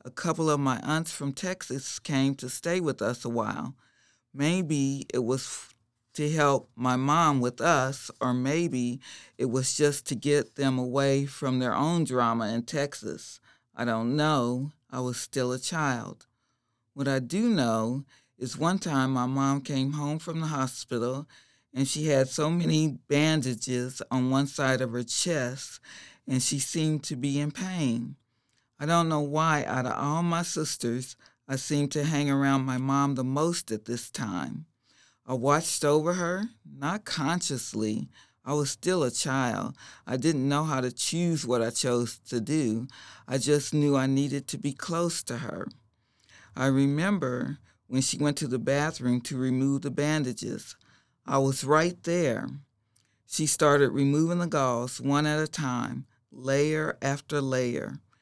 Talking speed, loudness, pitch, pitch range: 165 wpm, -28 LUFS, 140 Hz, 125-150 Hz